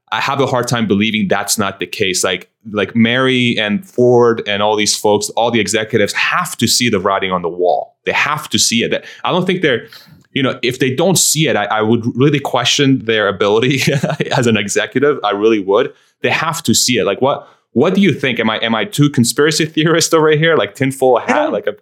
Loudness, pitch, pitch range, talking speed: -14 LUFS, 125 Hz, 110-145 Hz, 235 wpm